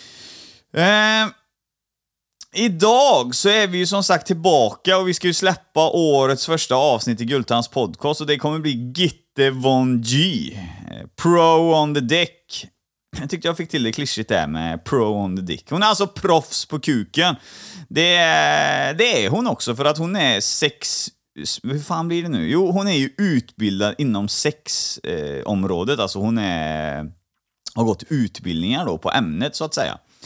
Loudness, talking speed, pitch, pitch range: -19 LUFS, 170 wpm, 150 Hz, 115-175 Hz